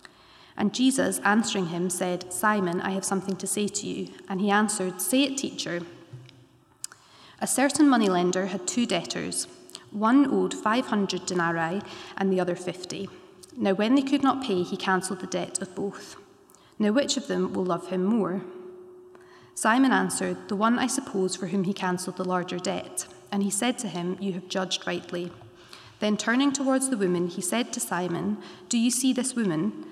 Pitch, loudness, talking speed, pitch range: 195 Hz, -26 LUFS, 180 wpm, 180-235 Hz